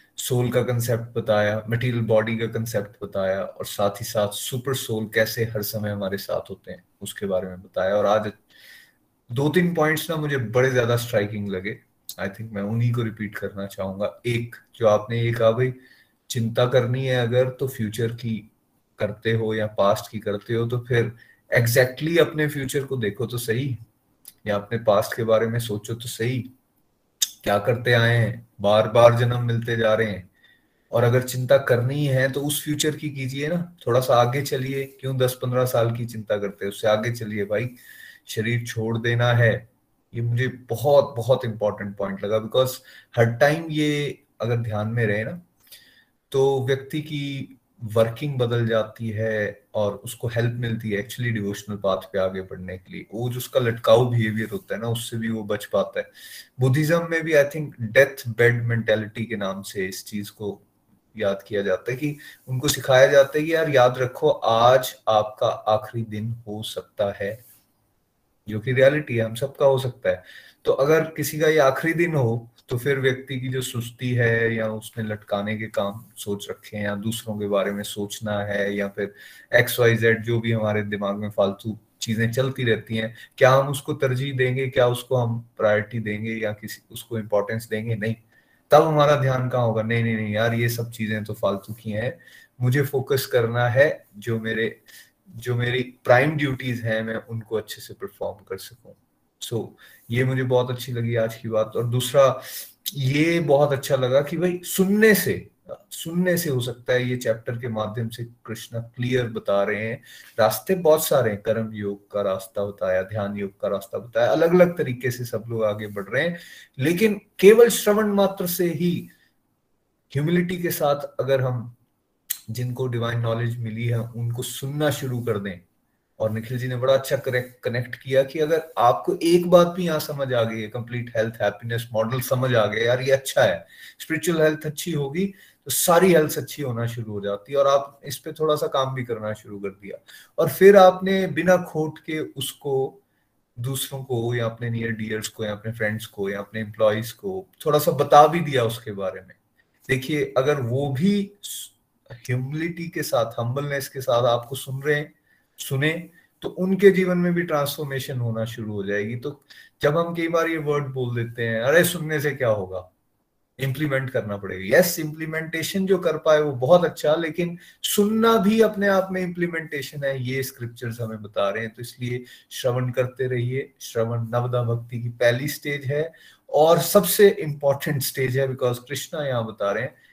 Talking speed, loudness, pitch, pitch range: 190 wpm, -23 LUFS, 120 Hz, 110-140 Hz